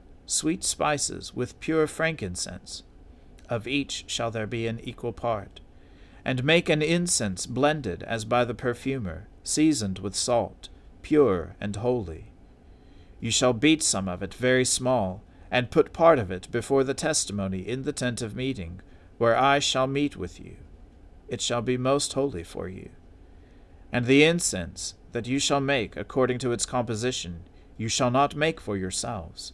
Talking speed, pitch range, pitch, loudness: 160 wpm, 90-130 Hz, 115 Hz, -26 LUFS